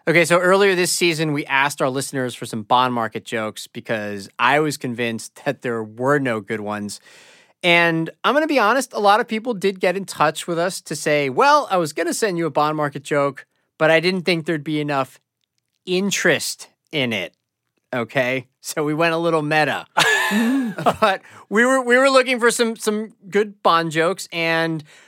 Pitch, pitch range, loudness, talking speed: 165 Hz, 140-200 Hz, -19 LUFS, 200 wpm